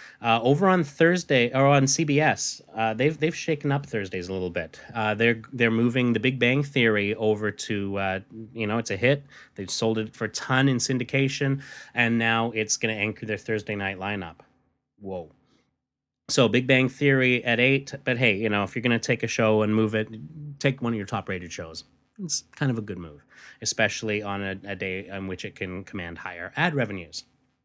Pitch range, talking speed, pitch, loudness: 105-135 Hz, 210 wpm, 115 Hz, -25 LUFS